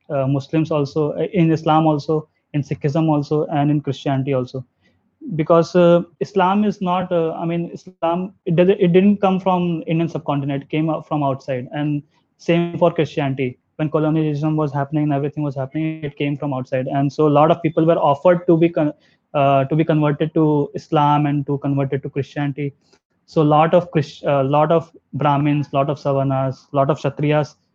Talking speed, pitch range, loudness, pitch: 185 wpm, 140-165 Hz, -19 LUFS, 150 Hz